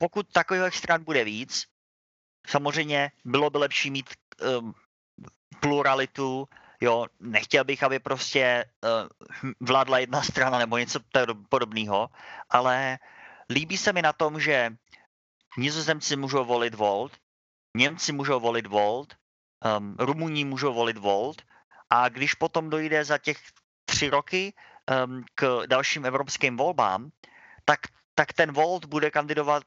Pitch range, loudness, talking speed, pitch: 120-150 Hz, -26 LUFS, 125 wpm, 135 Hz